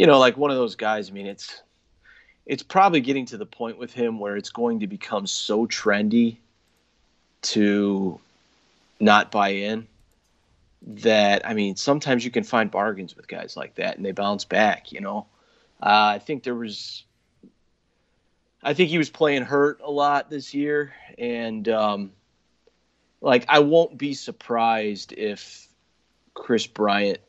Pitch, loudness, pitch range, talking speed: 110 Hz, -22 LUFS, 100-130 Hz, 160 wpm